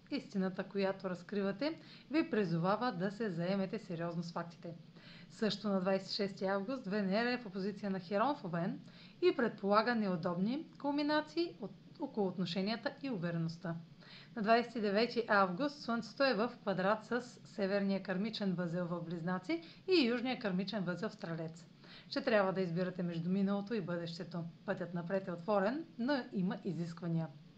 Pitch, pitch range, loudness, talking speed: 195 Hz, 180-225 Hz, -37 LUFS, 145 wpm